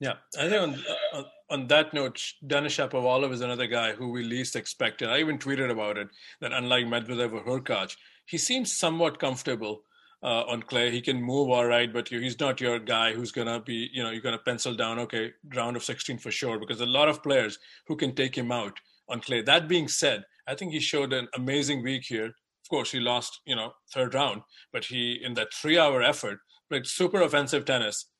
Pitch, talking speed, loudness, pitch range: 125 Hz, 220 wpm, -28 LUFS, 120-140 Hz